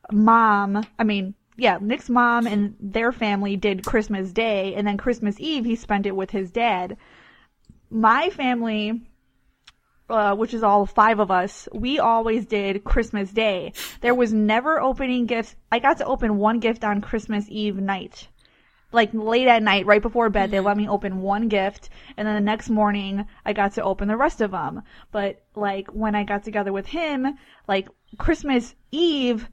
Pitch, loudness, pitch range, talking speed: 215 Hz, -22 LUFS, 205-235 Hz, 180 wpm